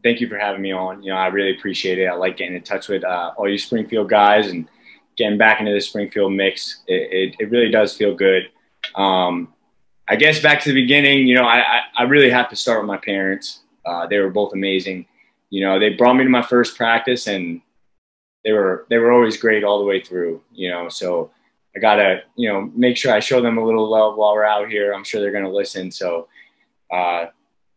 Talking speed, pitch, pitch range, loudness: 230 wpm, 105 Hz, 95-120 Hz, -17 LUFS